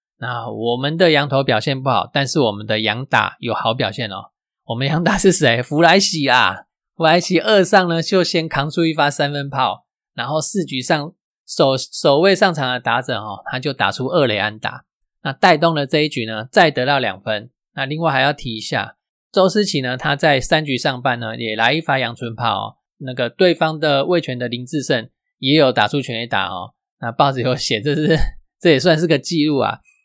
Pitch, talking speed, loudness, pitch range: 145 Hz, 285 characters per minute, -17 LUFS, 125-160 Hz